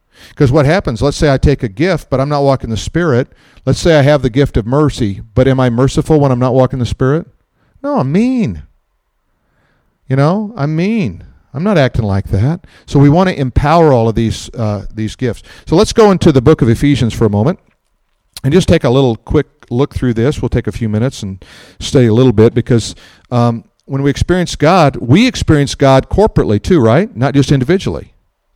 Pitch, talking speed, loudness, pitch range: 135 Hz, 210 wpm, -12 LUFS, 115-155 Hz